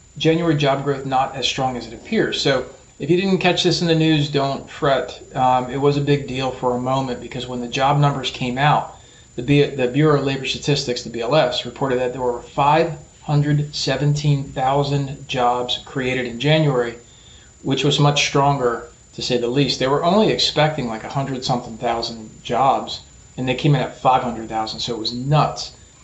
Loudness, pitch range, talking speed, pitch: -19 LUFS, 125-145 Hz, 185 wpm, 135 Hz